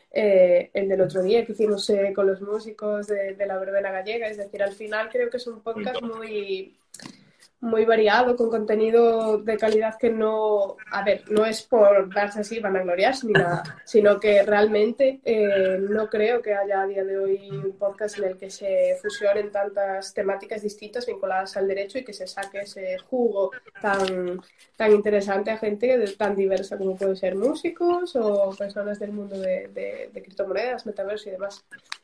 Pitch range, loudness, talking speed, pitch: 195-225 Hz, -24 LUFS, 185 wpm, 210 Hz